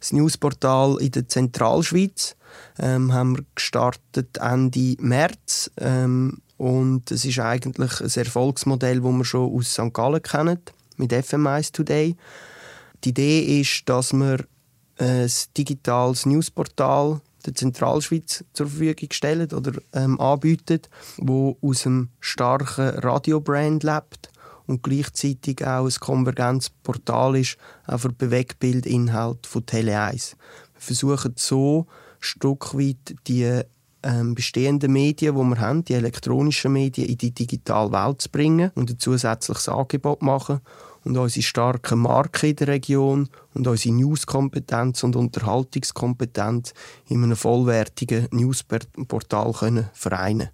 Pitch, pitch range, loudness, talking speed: 130 Hz, 125-140 Hz, -22 LUFS, 125 wpm